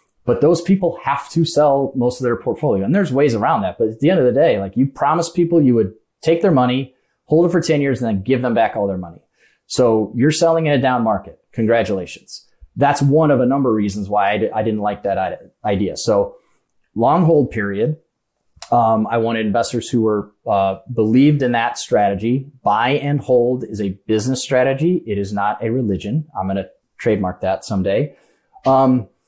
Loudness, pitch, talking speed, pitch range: -17 LUFS, 125 Hz, 205 wpm, 110-145 Hz